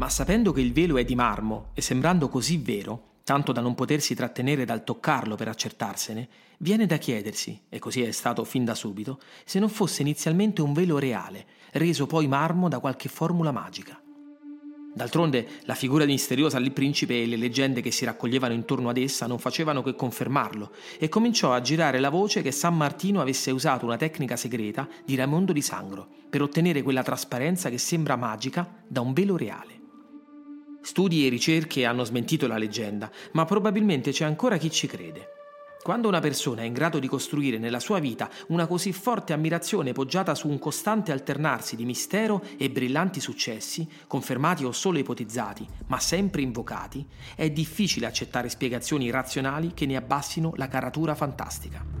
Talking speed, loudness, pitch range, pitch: 175 wpm, -26 LUFS, 125-170 Hz, 140 Hz